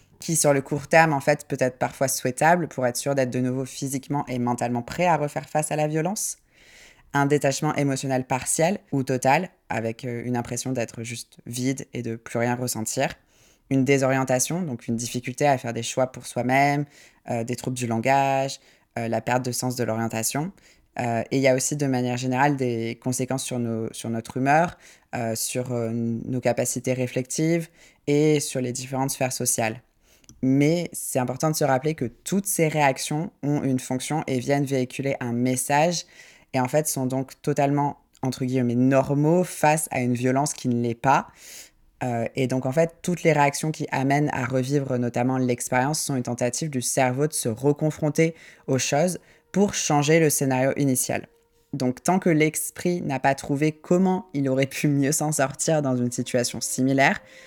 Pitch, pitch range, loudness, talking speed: 135 Hz, 125-150 Hz, -24 LUFS, 185 wpm